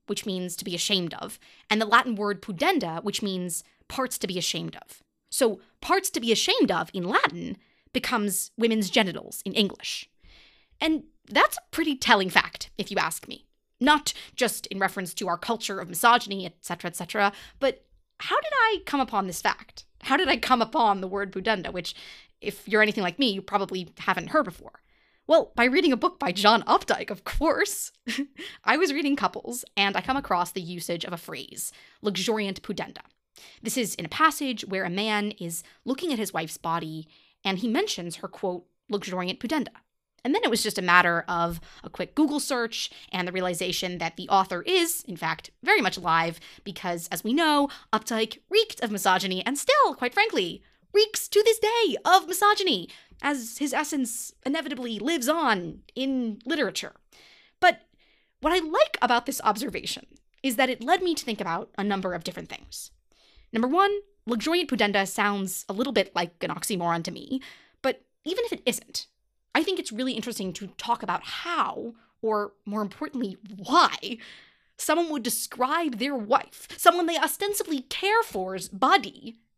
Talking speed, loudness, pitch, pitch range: 180 wpm, -26 LUFS, 225 Hz, 190-295 Hz